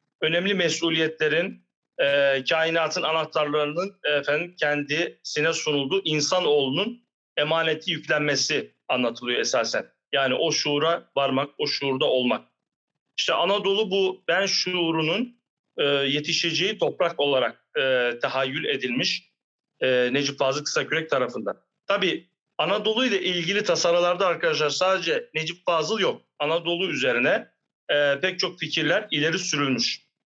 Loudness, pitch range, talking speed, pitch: -24 LUFS, 145-180 Hz, 105 wpm, 160 Hz